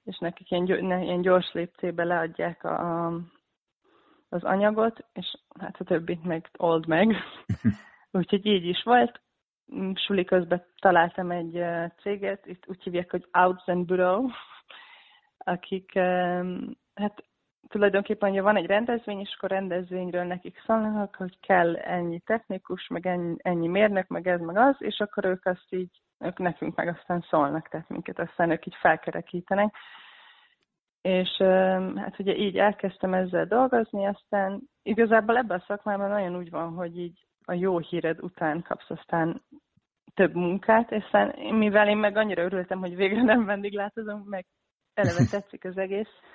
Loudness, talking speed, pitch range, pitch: -26 LUFS, 145 wpm, 175-205 Hz, 185 Hz